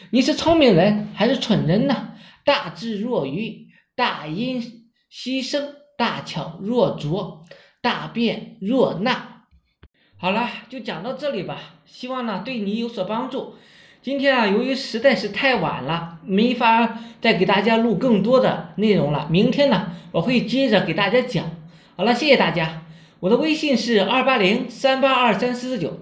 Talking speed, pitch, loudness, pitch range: 230 characters per minute, 230 Hz, -20 LUFS, 195-255 Hz